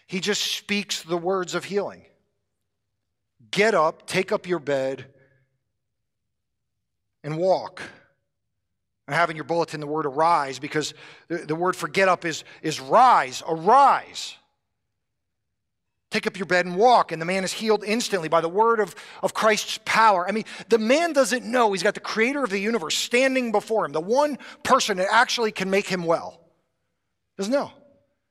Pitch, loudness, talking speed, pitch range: 175 Hz, -22 LUFS, 165 wpm, 130-210 Hz